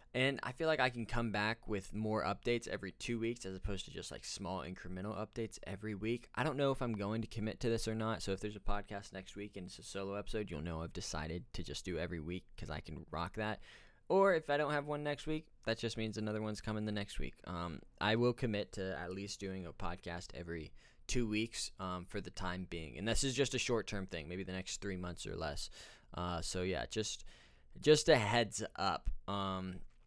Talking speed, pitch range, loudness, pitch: 240 wpm, 90-115 Hz, -39 LUFS, 105 Hz